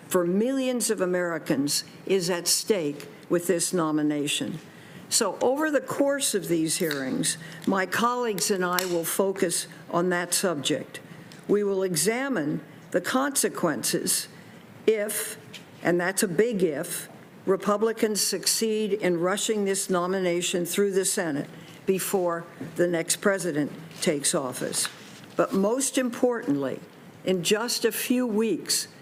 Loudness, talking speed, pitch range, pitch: -26 LUFS, 125 wpm, 170-215 Hz, 190 Hz